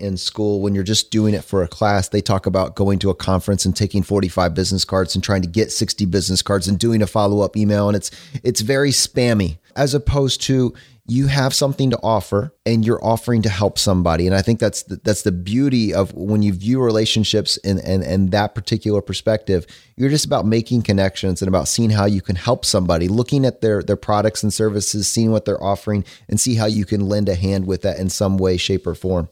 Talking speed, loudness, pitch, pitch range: 225 wpm, -18 LUFS, 105 Hz, 95-115 Hz